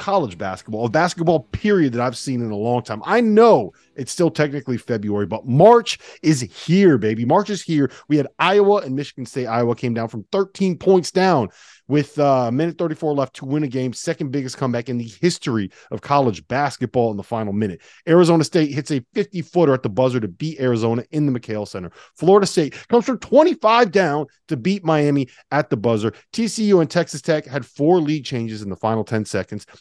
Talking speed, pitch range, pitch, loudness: 205 wpm, 120-175 Hz, 145 Hz, -19 LUFS